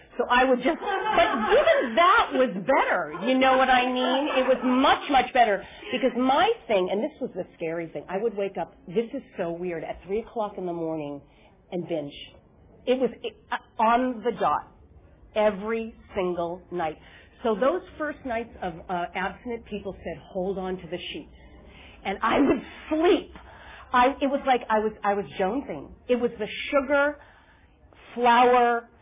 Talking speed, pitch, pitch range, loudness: 175 wpm, 230 Hz, 190-260 Hz, -25 LUFS